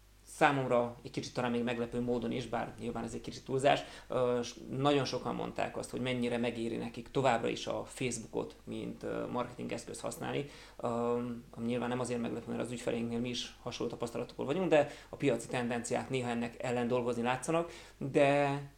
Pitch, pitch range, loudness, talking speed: 120 Hz, 120-135 Hz, -35 LUFS, 170 wpm